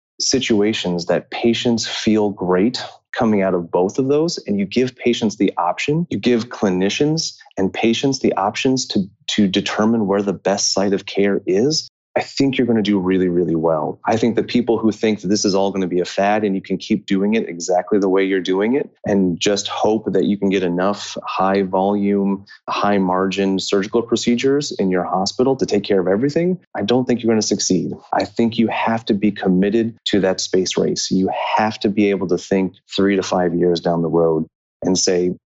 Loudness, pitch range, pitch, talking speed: -18 LUFS, 95-115 Hz, 100 Hz, 215 wpm